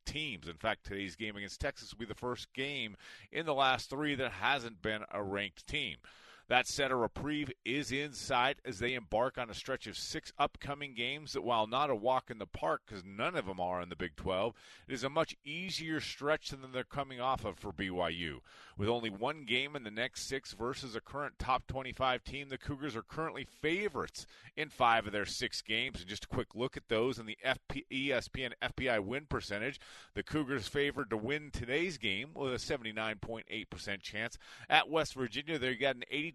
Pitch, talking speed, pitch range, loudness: 130 Hz, 210 wpm, 110-140 Hz, -36 LUFS